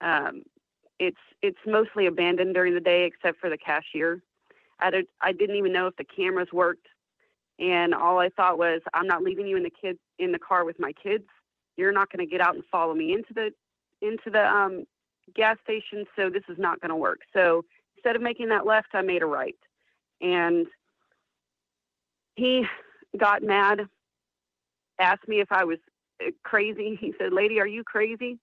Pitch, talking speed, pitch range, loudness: 190 Hz, 190 wpm, 175-220 Hz, -25 LUFS